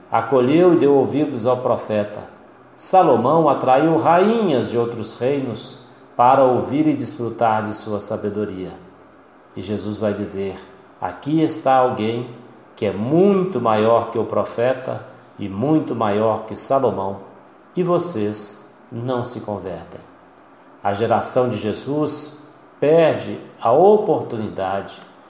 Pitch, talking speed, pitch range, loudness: 120 Hz, 120 wpm, 105-150 Hz, -19 LUFS